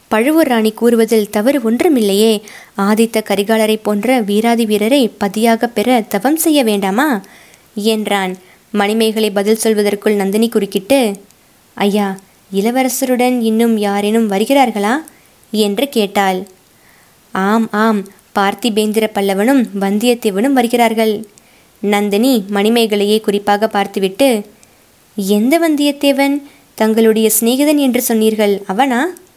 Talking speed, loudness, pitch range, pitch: 90 wpm, -14 LUFS, 205-245 Hz, 220 Hz